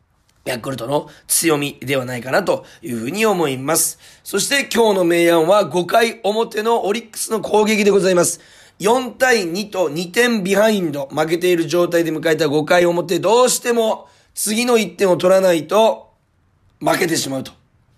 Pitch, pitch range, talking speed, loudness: 180 Hz, 160-215 Hz, 305 characters per minute, -17 LUFS